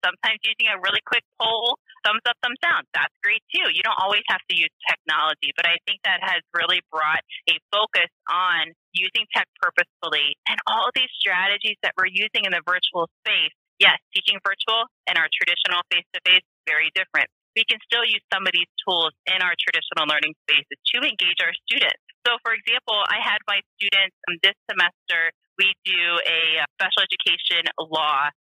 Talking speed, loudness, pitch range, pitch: 180 wpm, -20 LUFS, 170-220 Hz, 190 Hz